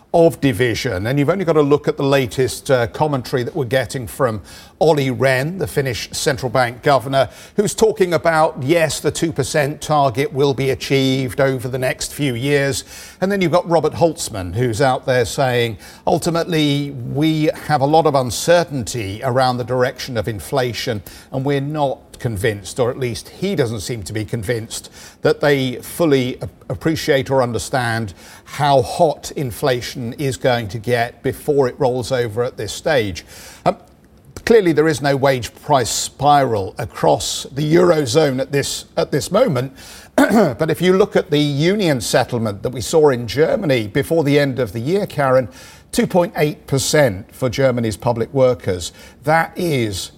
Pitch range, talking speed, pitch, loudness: 120-155 Hz, 170 wpm, 135 Hz, -18 LUFS